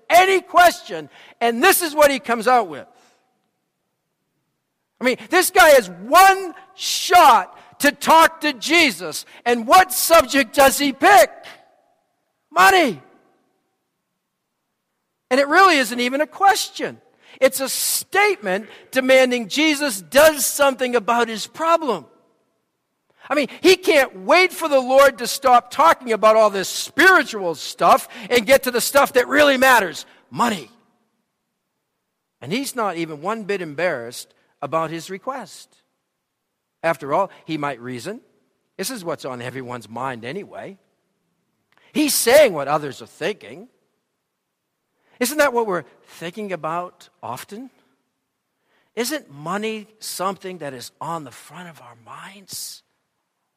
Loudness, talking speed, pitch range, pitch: -17 LUFS, 130 wpm, 195-315 Hz, 255 Hz